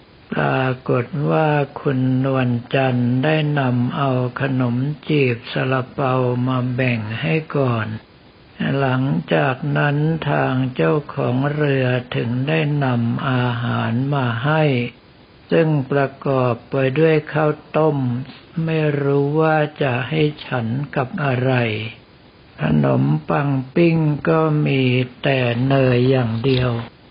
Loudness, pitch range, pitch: -19 LUFS, 125-150 Hz, 135 Hz